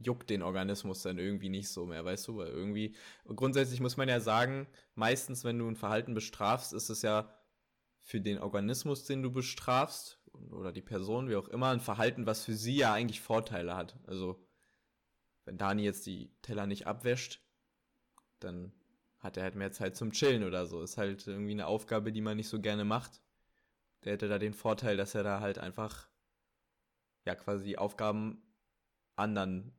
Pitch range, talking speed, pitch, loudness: 95-115 Hz, 185 wpm, 105 Hz, -36 LUFS